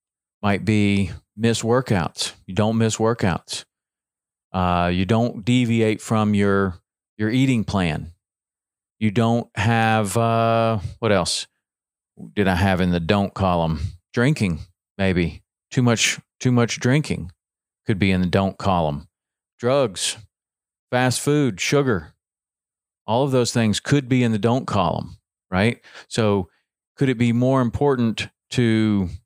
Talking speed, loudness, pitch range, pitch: 135 wpm, -21 LUFS, 95-115 Hz, 105 Hz